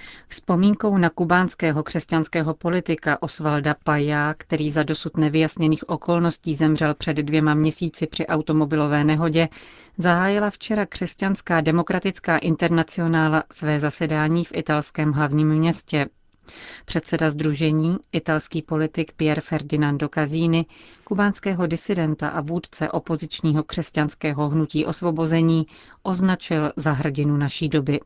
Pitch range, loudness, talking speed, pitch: 155-170 Hz, -22 LUFS, 105 wpm, 160 Hz